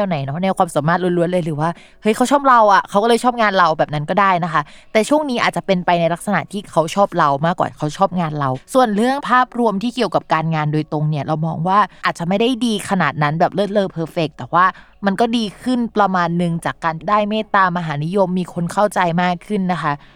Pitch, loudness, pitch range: 185 Hz, -17 LUFS, 165-210 Hz